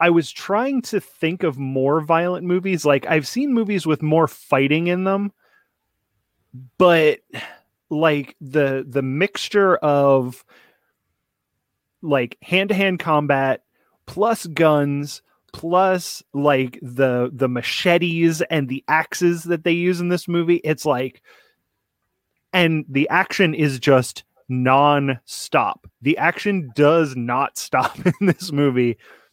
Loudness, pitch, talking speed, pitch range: -19 LUFS, 155 Hz, 120 wpm, 135-180 Hz